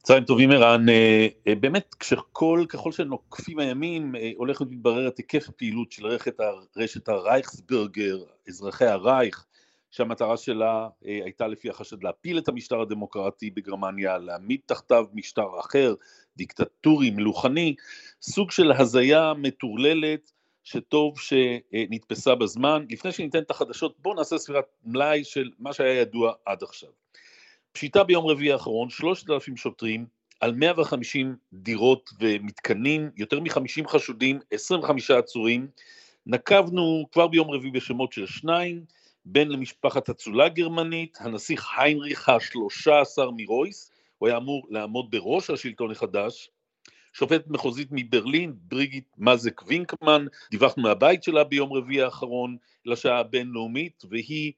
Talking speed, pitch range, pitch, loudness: 120 wpm, 115-155 Hz, 135 Hz, -24 LUFS